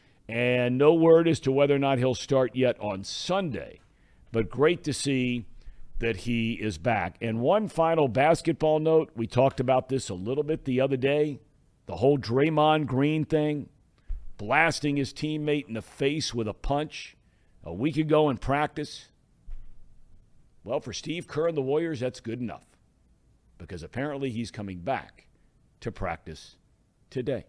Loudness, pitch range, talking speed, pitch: -26 LUFS, 115-150 Hz, 160 wpm, 135 Hz